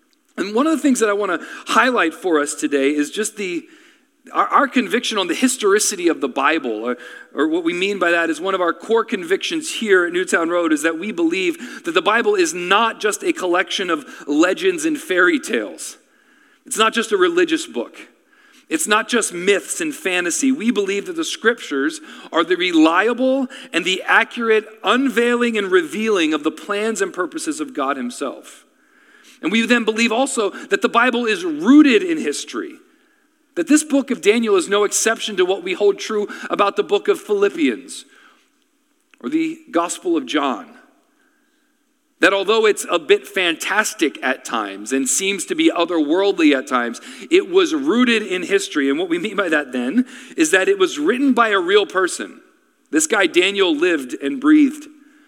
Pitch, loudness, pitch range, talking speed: 270 Hz, -18 LUFS, 205-330 Hz, 185 wpm